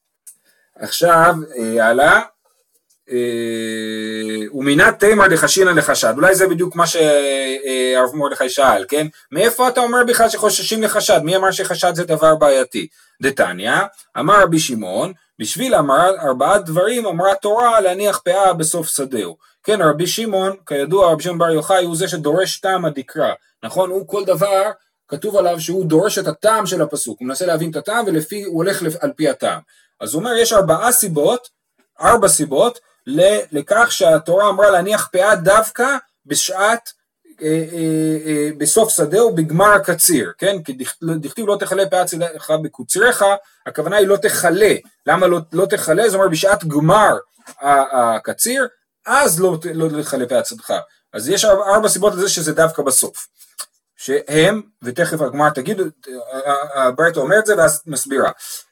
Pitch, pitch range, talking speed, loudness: 180 Hz, 150-205 Hz, 150 wpm, -15 LUFS